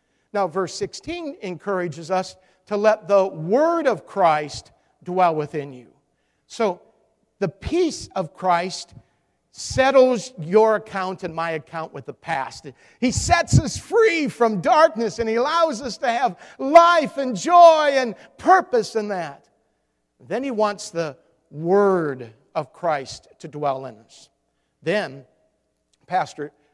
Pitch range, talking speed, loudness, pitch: 160-260 Hz, 135 wpm, -20 LUFS, 195 Hz